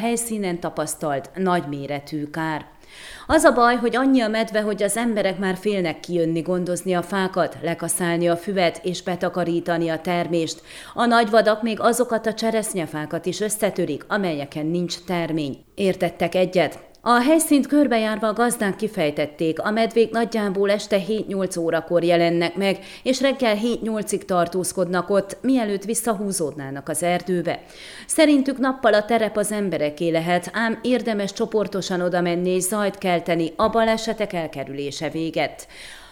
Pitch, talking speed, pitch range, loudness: 185 Hz, 135 wpm, 170-220 Hz, -22 LUFS